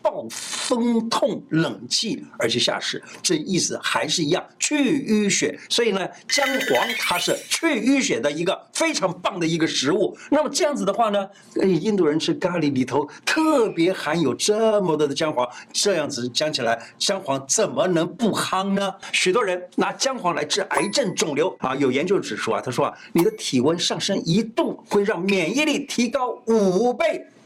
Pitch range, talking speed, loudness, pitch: 165-265 Hz, 260 characters per minute, -22 LUFS, 200 Hz